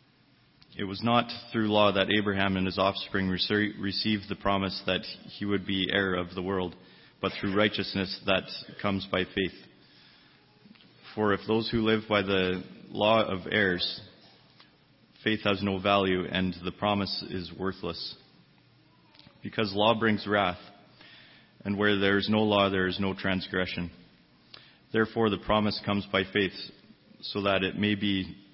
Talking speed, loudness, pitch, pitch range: 150 wpm, -28 LUFS, 100 Hz, 95-105 Hz